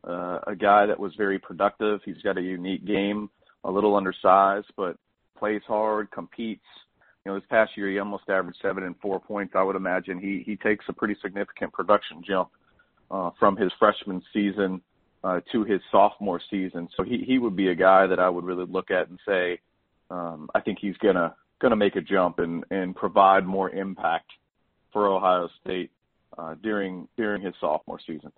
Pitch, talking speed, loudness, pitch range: 95 Hz, 190 wpm, -25 LUFS, 90-105 Hz